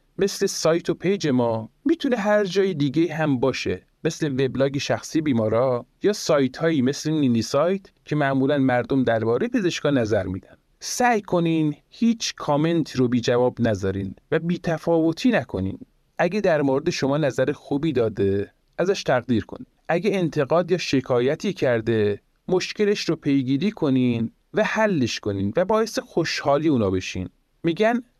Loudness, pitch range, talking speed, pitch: -22 LUFS, 125-185 Hz, 145 wpm, 150 Hz